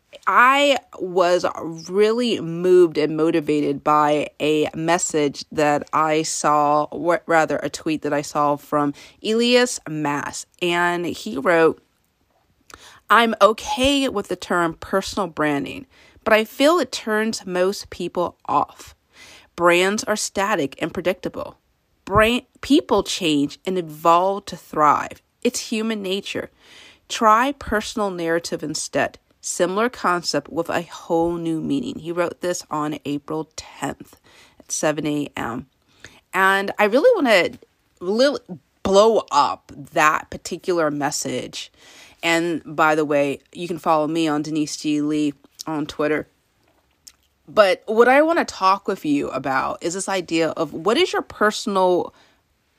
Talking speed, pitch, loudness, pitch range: 130 wpm, 175 Hz, -20 LUFS, 155-210 Hz